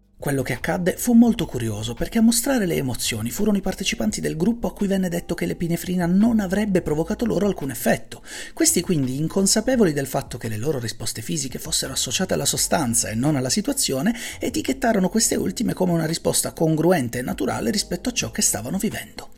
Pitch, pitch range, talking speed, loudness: 180 Hz, 135-215 Hz, 190 wpm, -22 LUFS